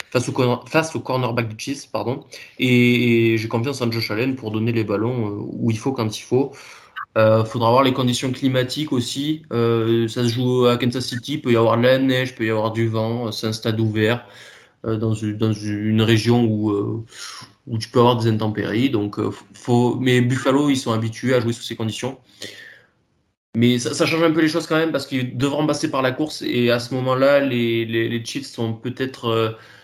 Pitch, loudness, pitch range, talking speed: 120 Hz, -20 LUFS, 115-130 Hz, 220 wpm